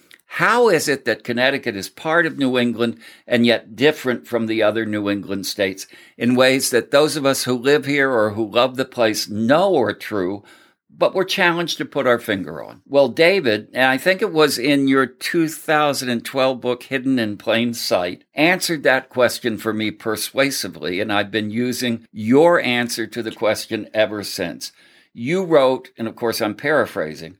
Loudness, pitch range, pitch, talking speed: -19 LUFS, 110-140 Hz, 125 Hz, 180 wpm